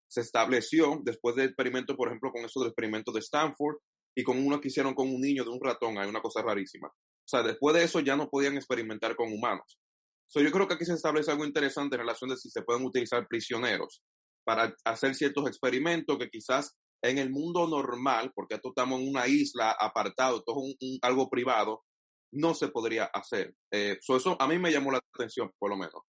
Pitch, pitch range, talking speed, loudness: 135 Hz, 120-150 Hz, 210 wpm, -30 LUFS